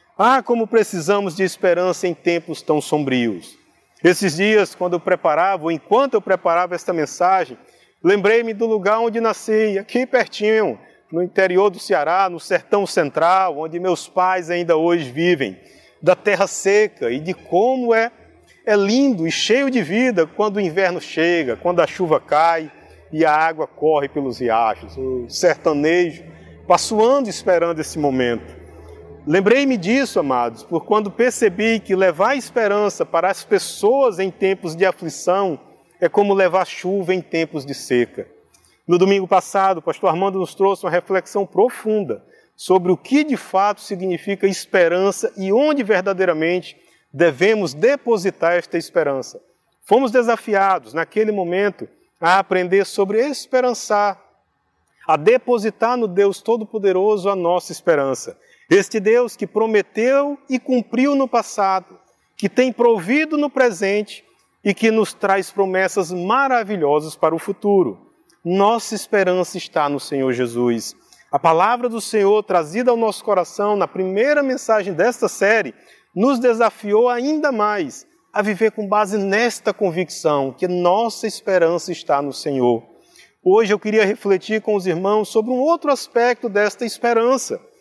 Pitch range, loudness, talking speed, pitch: 175-225 Hz, -18 LUFS, 140 wpm, 195 Hz